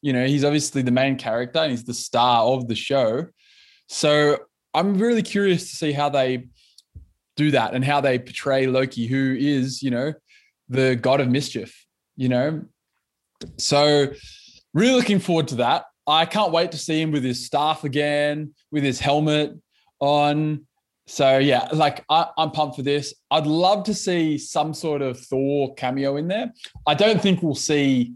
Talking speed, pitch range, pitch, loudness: 175 wpm, 130-155 Hz, 145 Hz, -21 LUFS